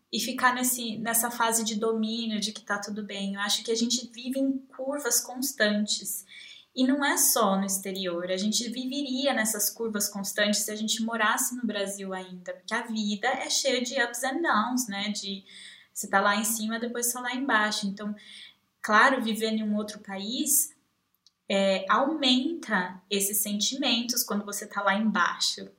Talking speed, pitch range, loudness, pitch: 175 wpm, 205-250 Hz, -27 LUFS, 220 Hz